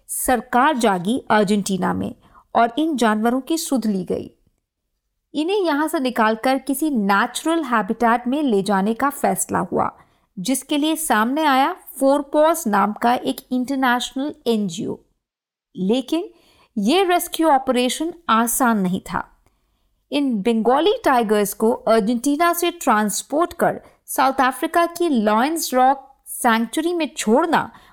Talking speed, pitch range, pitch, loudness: 125 wpm, 230-310 Hz, 260 Hz, -19 LUFS